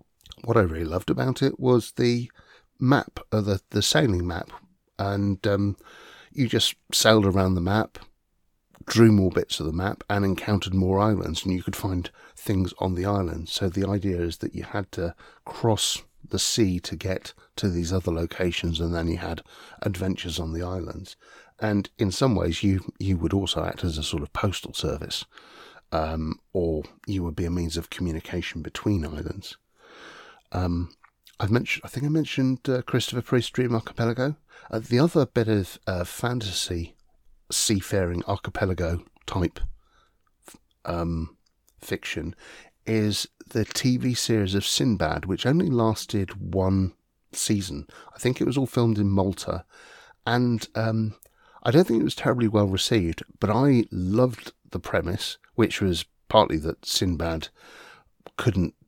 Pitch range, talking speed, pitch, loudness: 85-110 Hz, 160 wpm, 100 Hz, -25 LUFS